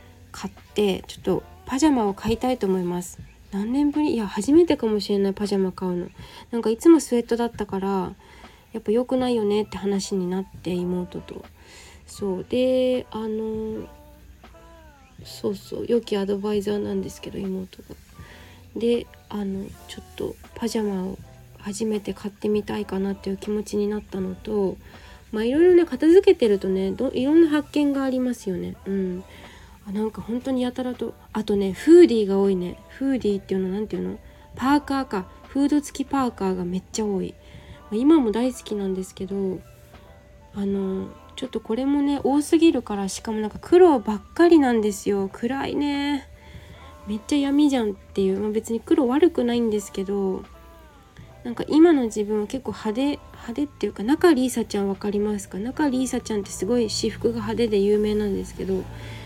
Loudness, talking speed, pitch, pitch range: -23 LUFS, 365 characters per minute, 210 Hz, 195-255 Hz